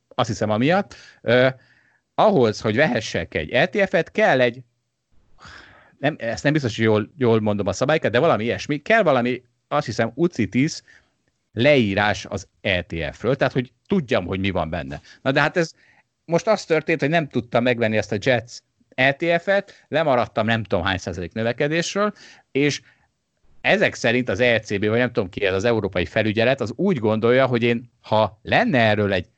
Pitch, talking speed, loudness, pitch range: 120 Hz, 170 wpm, -21 LUFS, 110-145 Hz